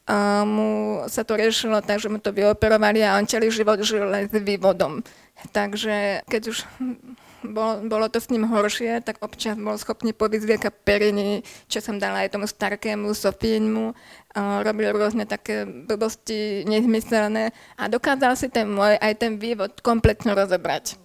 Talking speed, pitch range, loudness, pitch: 155 wpm, 205-225 Hz, -23 LUFS, 215 Hz